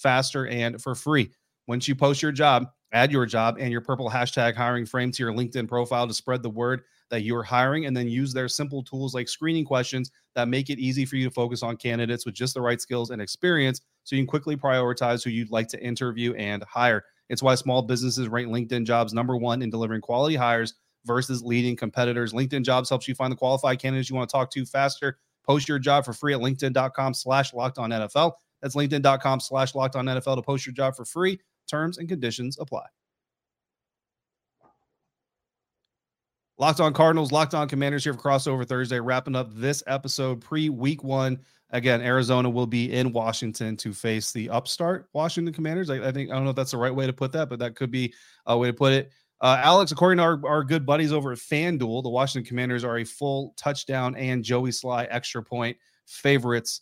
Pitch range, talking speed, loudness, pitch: 120-140 Hz, 210 wpm, -25 LUFS, 130 Hz